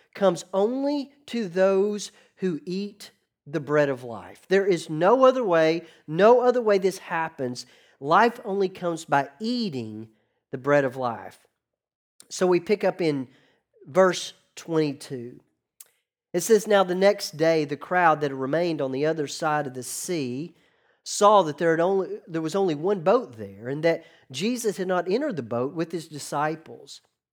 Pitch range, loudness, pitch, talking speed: 140-195 Hz, -24 LUFS, 165 Hz, 165 wpm